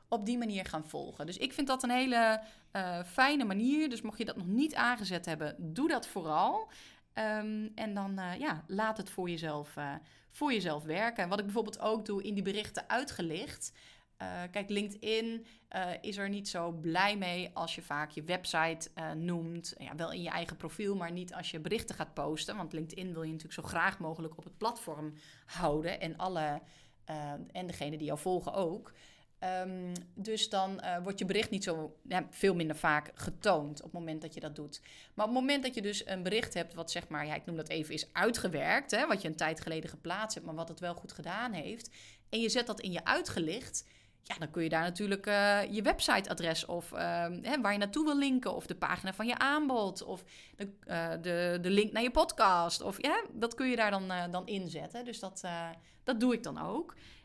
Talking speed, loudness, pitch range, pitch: 220 wpm, -35 LUFS, 165-220 Hz, 185 Hz